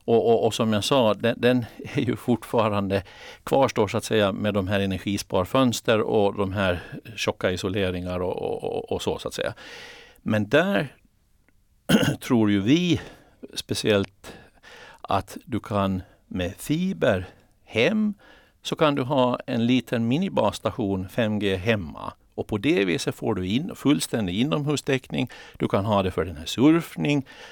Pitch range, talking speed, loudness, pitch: 100-130 Hz, 155 wpm, -24 LUFS, 110 Hz